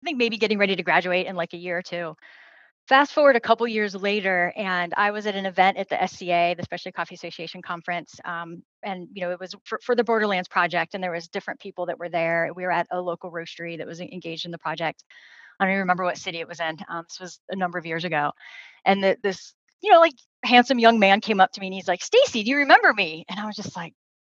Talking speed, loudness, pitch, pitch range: 265 wpm, -23 LUFS, 185 Hz, 170-210 Hz